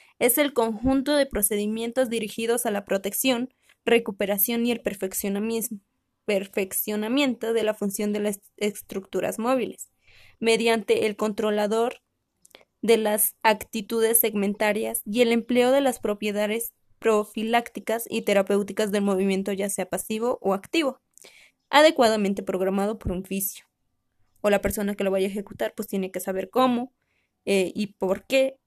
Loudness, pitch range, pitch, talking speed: -24 LUFS, 200-235 Hz, 215 Hz, 135 wpm